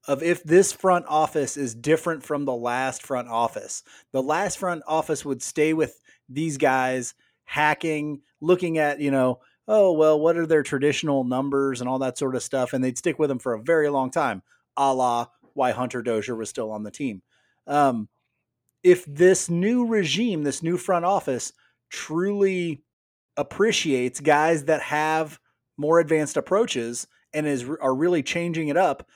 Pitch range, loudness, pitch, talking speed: 130-165 Hz, -23 LUFS, 150 Hz, 170 wpm